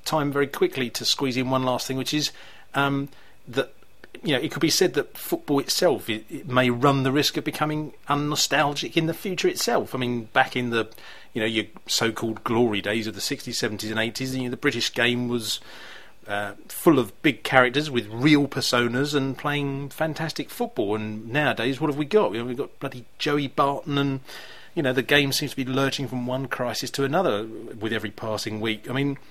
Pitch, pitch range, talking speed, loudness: 130 Hz, 120-145 Hz, 215 wpm, -24 LUFS